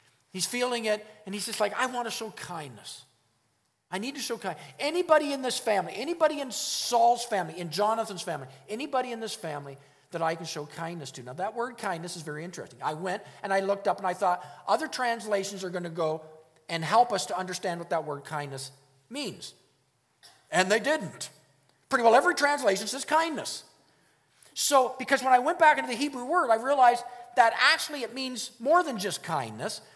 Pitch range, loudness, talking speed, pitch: 170-255 Hz, -27 LUFS, 200 wpm, 215 Hz